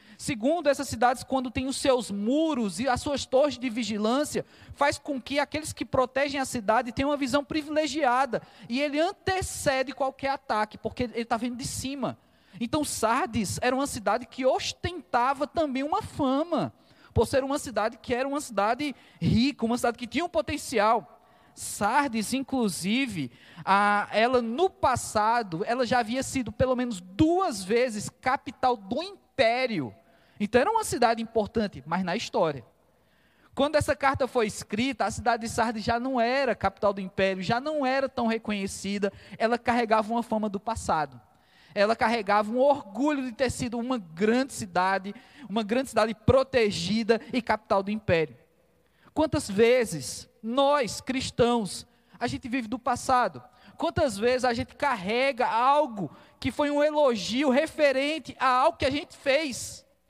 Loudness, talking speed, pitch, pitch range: -27 LUFS, 155 wpm, 250 Hz, 220-275 Hz